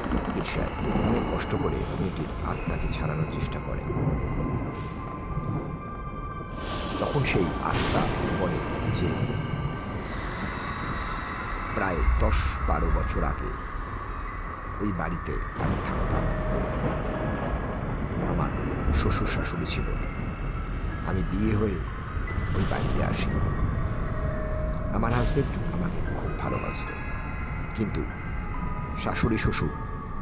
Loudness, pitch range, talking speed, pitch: -29 LUFS, 80-105 Hz, 80 wpm, 90 Hz